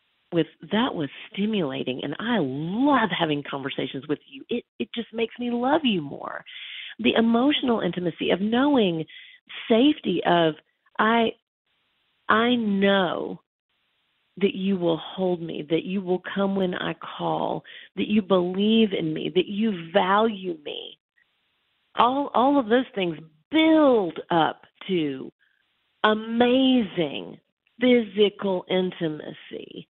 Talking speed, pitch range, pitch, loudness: 120 wpm, 170-245 Hz, 205 Hz, -24 LUFS